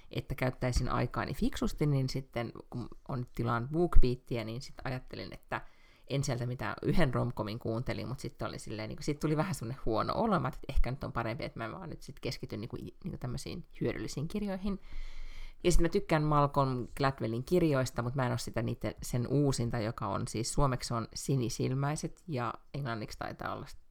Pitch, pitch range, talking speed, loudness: 130 Hz, 120-150 Hz, 185 wpm, -34 LUFS